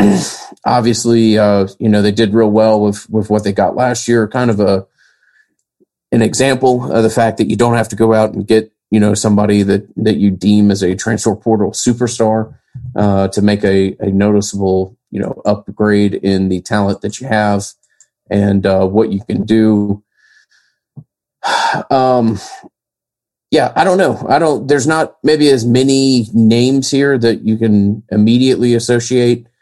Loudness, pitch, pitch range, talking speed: -13 LUFS, 110 Hz, 100-120 Hz, 170 wpm